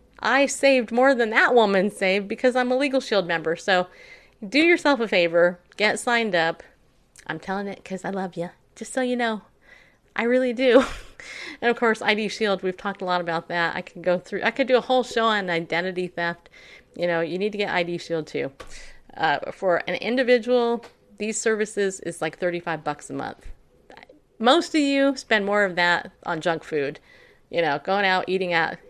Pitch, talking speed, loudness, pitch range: 200 Hz, 200 wpm, -23 LUFS, 175-235 Hz